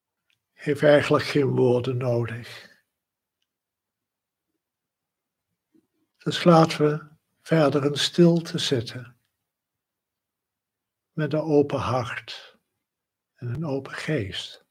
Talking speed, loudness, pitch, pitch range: 80 wpm, -23 LUFS, 140 Hz, 125-155 Hz